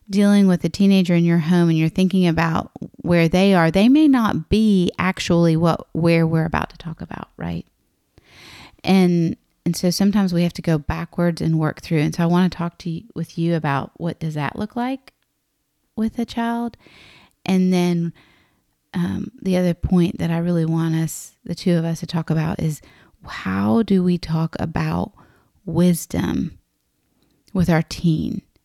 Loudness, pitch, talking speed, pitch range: -20 LUFS, 170 Hz, 180 wpm, 165-185 Hz